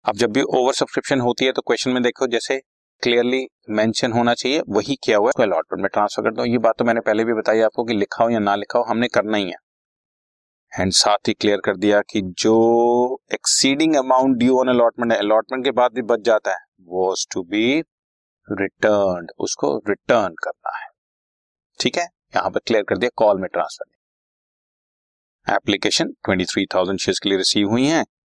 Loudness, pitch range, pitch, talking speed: -19 LUFS, 105-125 Hz, 115 Hz, 195 wpm